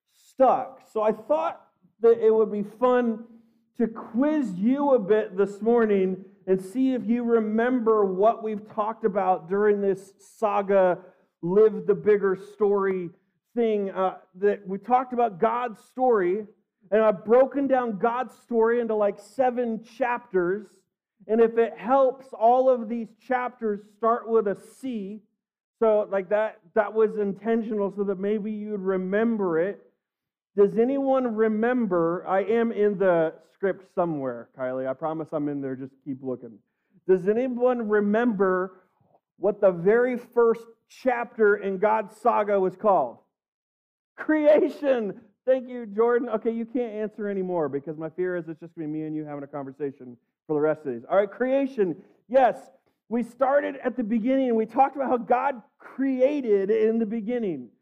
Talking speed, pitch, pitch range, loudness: 160 wpm, 215 Hz, 195-235 Hz, -25 LUFS